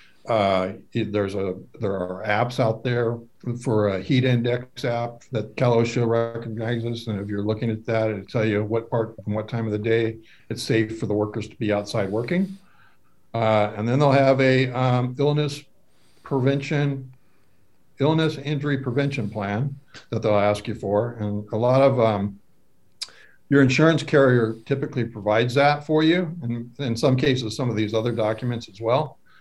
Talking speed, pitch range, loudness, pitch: 175 wpm, 110-135 Hz, -23 LUFS, 115 Hz